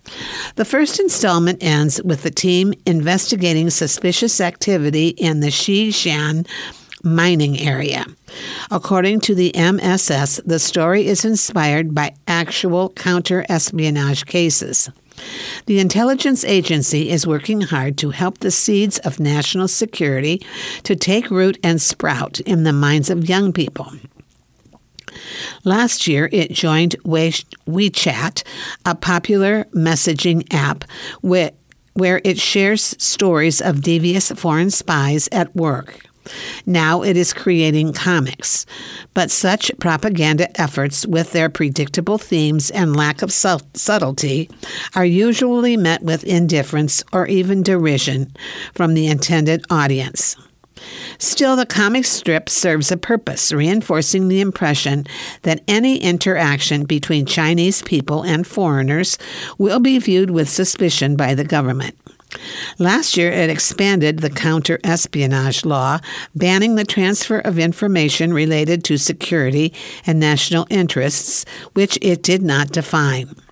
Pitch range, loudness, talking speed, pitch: 155-190 Hz, -16 LUFS, 120 wpm, 170 Hz